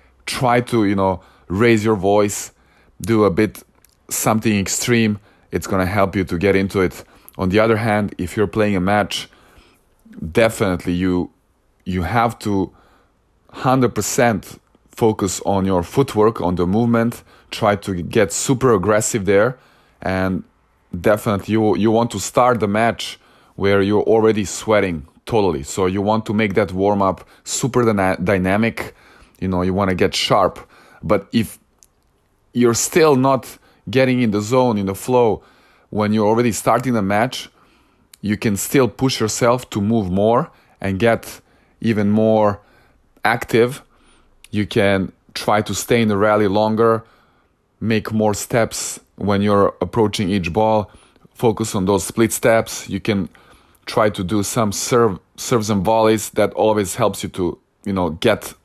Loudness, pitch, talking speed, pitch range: -18 LUFS, 105 Hz, 155 wpm, 95-115 Hz